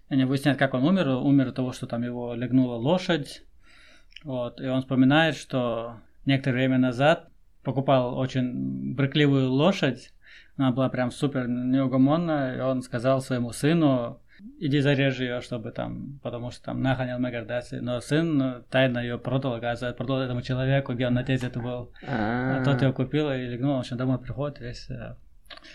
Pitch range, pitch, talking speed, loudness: 125-140 Hz, 130 Hz, 160 wpm, -26 LUFS